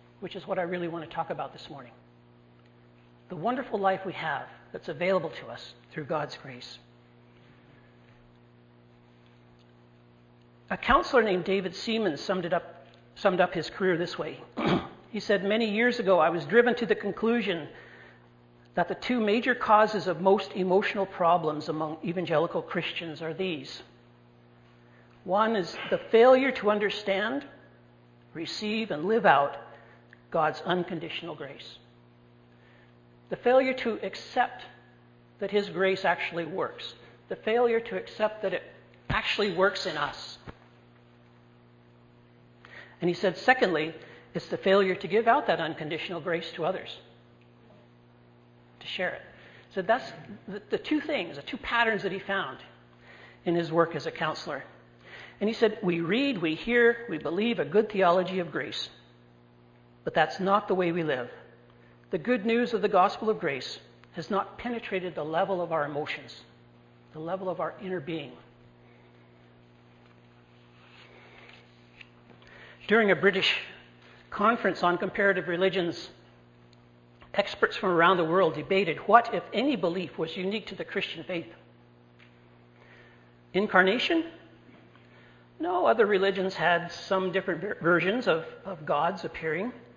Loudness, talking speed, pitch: -27 LUFS, 140 wpm, 165 Hz